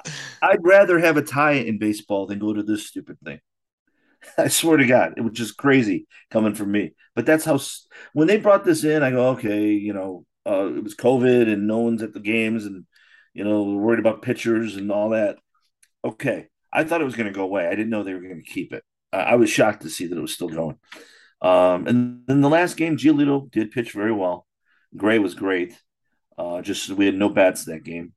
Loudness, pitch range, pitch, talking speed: -21 LUFS, 105-155 Hz, 115 Hz, 230 wpm